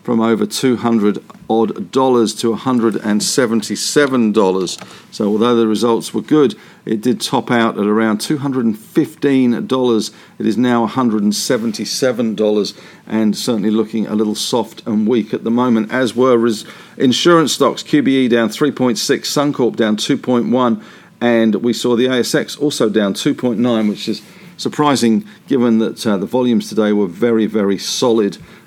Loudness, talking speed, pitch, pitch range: -15 LUFS, 185 wpm, 115 Hz, 110-130 Hz